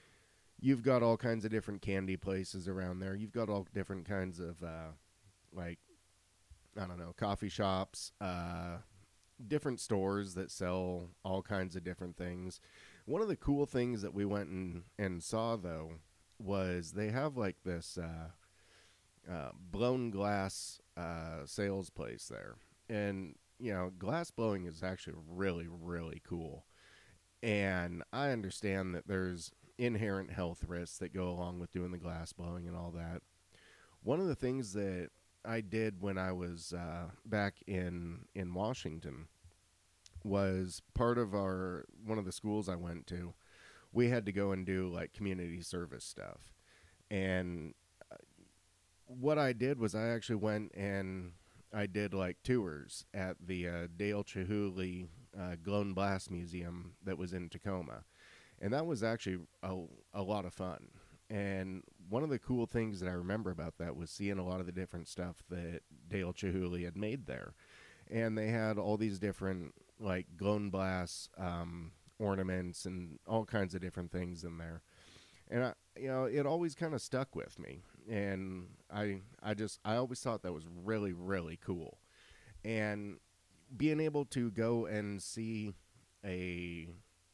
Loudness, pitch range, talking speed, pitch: -39 LUFS, 90-105 Hz, 160 wpm, 95 Hz